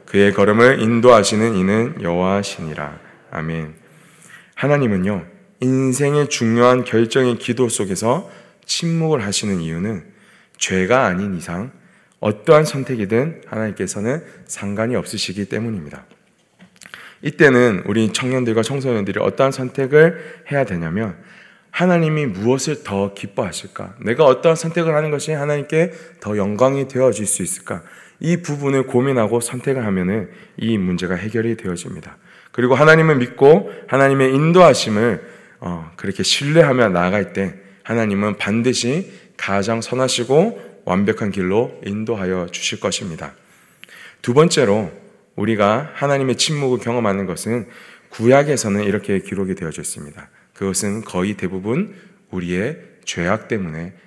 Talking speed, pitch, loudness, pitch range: 315 characters per minute, 120 Hz, -18 LUFS, 100-140 Hz